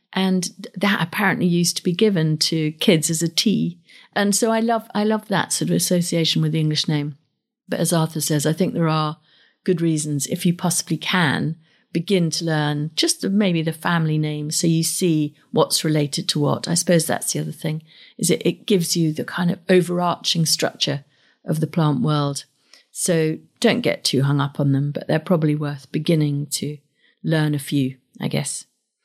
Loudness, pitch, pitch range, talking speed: -20 LUFS, 165 Hz, 150-180 Hz, 195 wpm